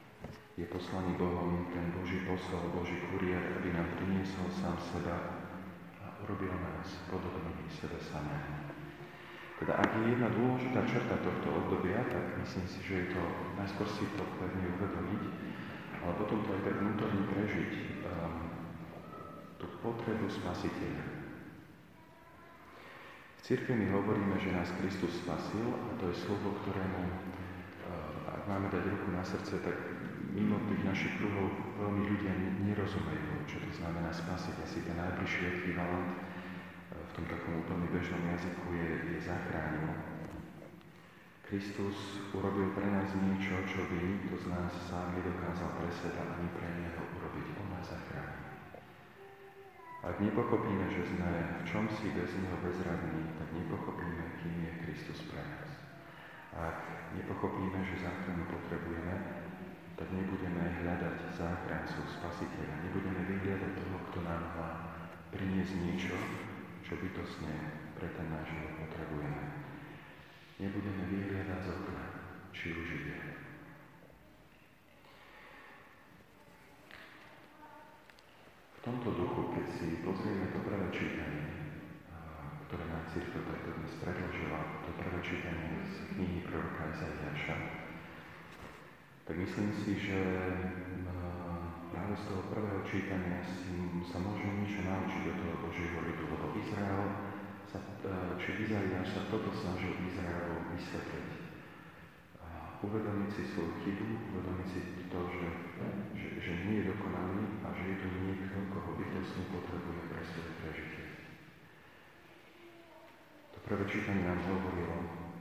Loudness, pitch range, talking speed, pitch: -38 LUFS, 85-95 Hz, 130 wpm, 90 Hz